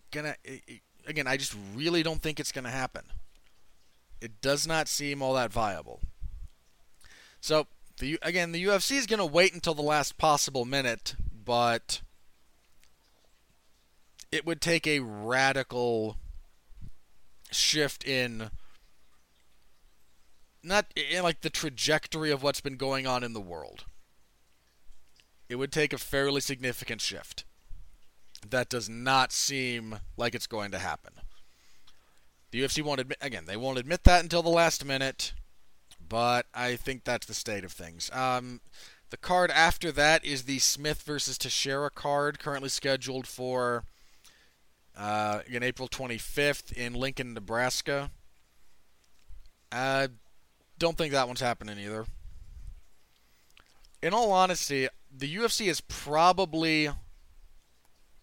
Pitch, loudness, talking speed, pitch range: 130 Hz, -29 LUFS, 130 wpm, 105-150 Hz